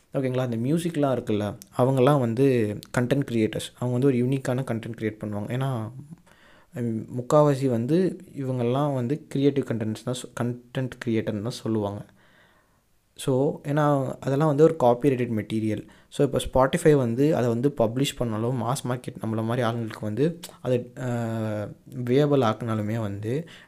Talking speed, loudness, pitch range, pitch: 130 wpm, -25 LUFS, 115-140 Hz, 125 Hz